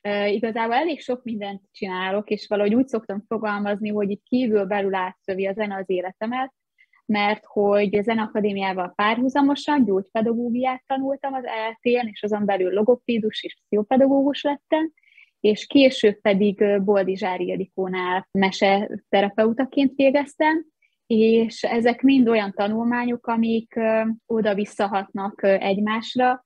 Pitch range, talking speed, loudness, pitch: 205-250 Hz, 115 wpm, -22 LUFS, 215 Hz